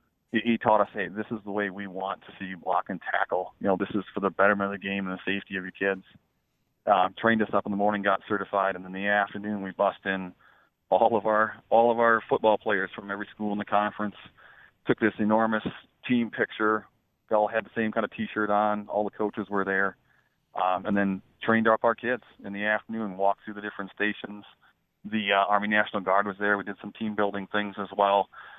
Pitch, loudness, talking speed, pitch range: 105 Hz, -27 LUFS, 235 wpm, 100-110 Hz